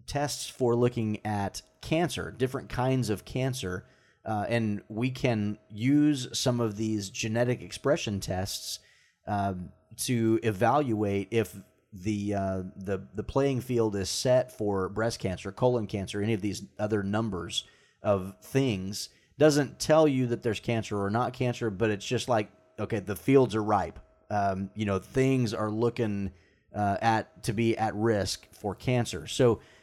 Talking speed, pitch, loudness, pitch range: 155 wpm, 110 Hz, -29 LUFS, 100-125 Hz